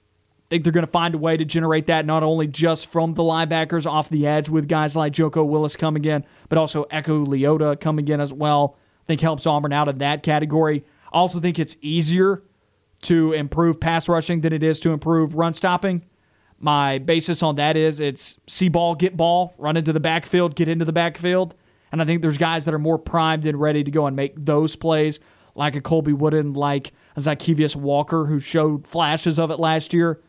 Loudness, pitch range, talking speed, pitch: -20 LUFS, 150-165 Hz, 215 wpm, 160 Hz